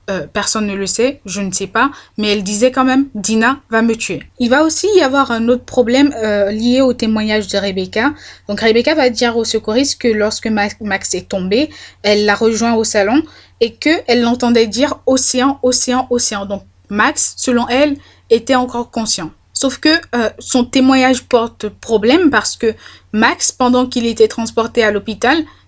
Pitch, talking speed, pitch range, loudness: 235 Hz, 180 wpm, 215-255 Hz, -14 LUFS